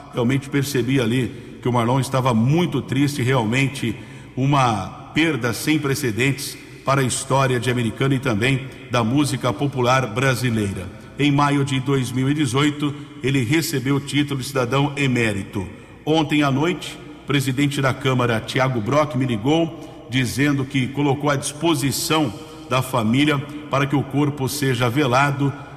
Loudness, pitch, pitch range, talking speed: -20 LUFS, 135 Hz, 125-145 Hz, 140 wpm